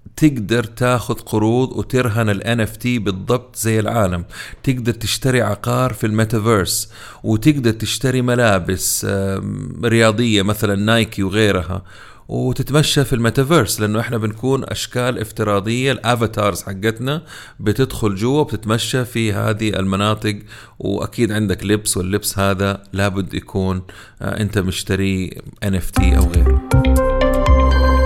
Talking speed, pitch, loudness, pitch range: 105 wpm, 110 Hz, -18 LUFS, 100-120 Hz